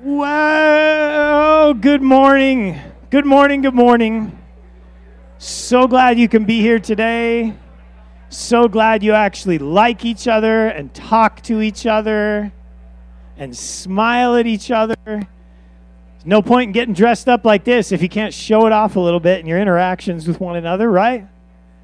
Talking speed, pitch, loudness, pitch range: 150 wpm, 220 Hz, -14 LUFS, 170-240 Hz